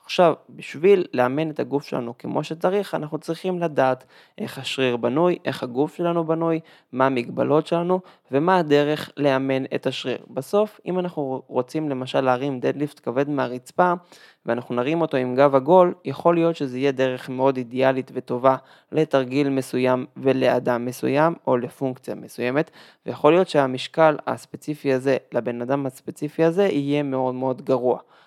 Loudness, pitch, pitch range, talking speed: -22 LUFS, 140 Hz, 130-160 Hz, 145 wpm